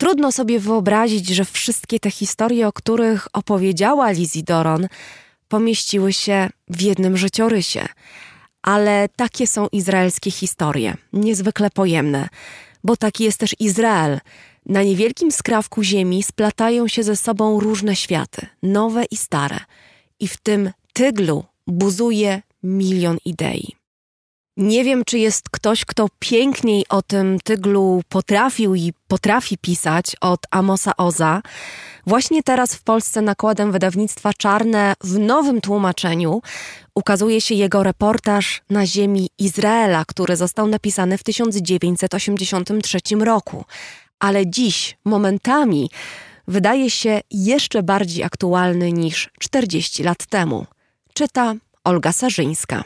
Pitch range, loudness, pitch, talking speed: 185-220 Hz, -18 LUFS, 205 Hz, 120 wpm